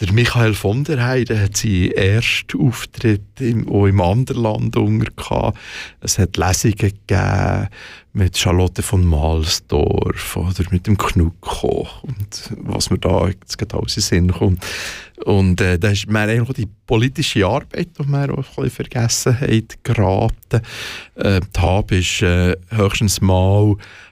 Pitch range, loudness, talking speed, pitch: 95-115 Hz, -18 LUFS, 125 wpm, 105 Hz